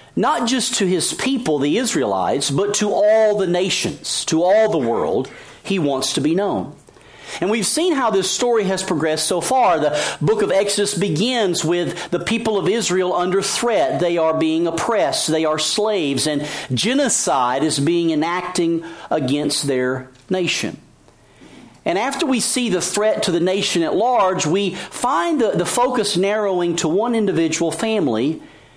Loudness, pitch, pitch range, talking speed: -18 LUFS, 180 Hz, 165-215 Hz, 165 wpm